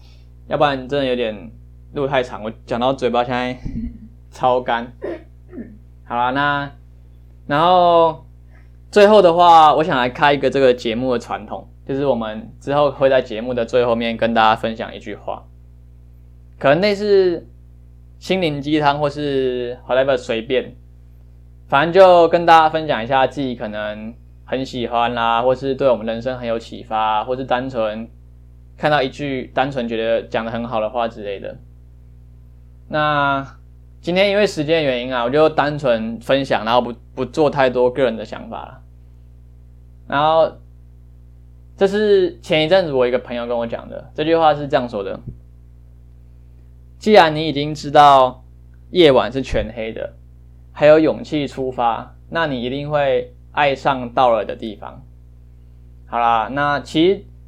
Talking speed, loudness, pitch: 235 characters per minute, -17 LUFS, 120 Hz